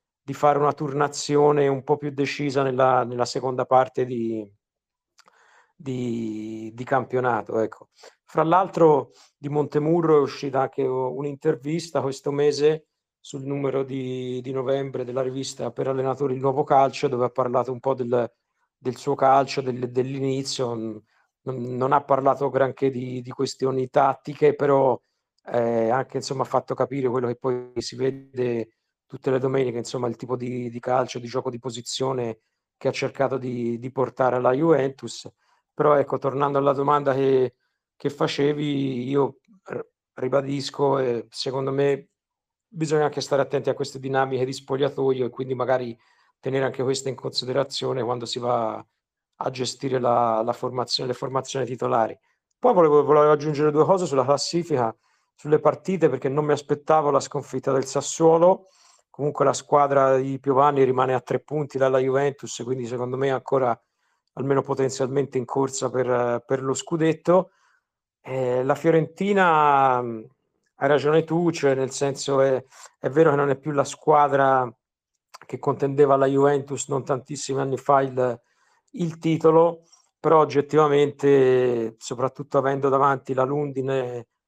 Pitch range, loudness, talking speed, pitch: 130-145 Hz, -23 LUFS, 150 wpm, 135 Hz